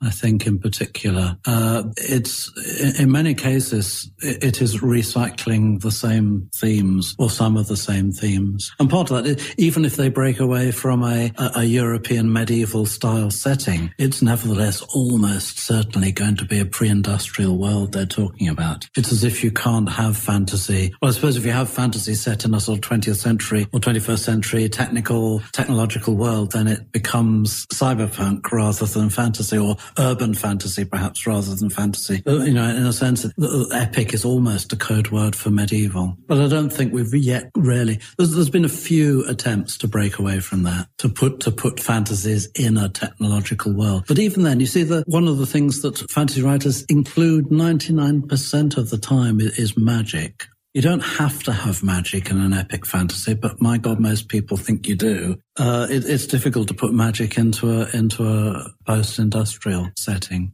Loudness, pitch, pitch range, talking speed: -20 LUFS, 115 Hz, 105-130 Hz, 180 wpm